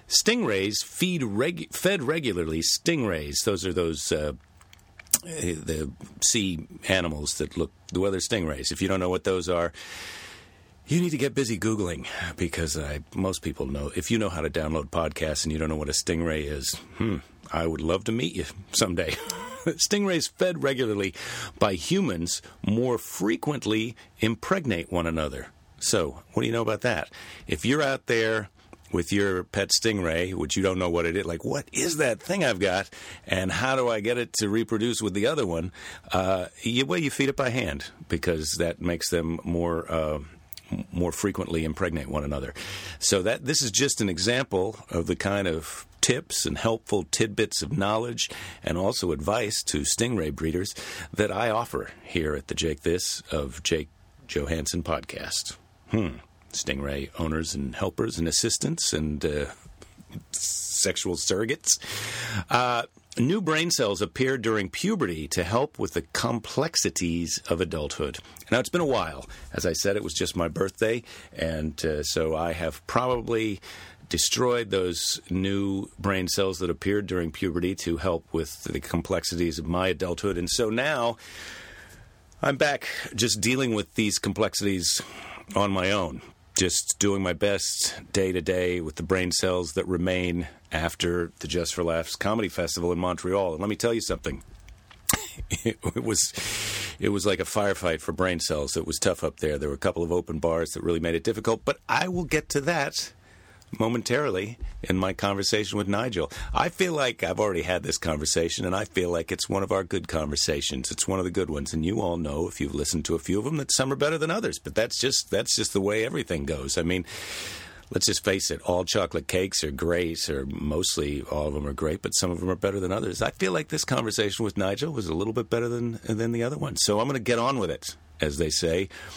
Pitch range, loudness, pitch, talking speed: 80-110 Hz, -27 LUFS, 90 Hz, 190 wpm